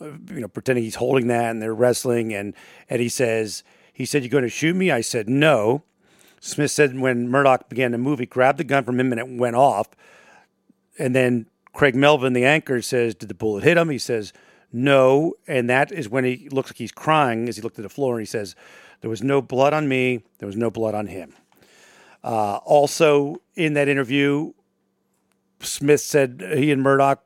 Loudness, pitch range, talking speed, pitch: -20 LUFS, 120-145 Hz, 210 wpm, 130 Hz